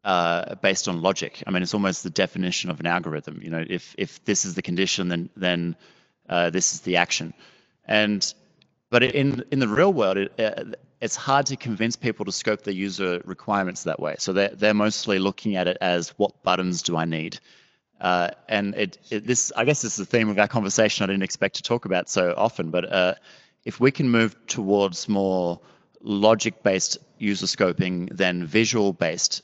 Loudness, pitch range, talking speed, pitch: -23 LUFS, 90-110 Hz, 195 wpm, 100 Hz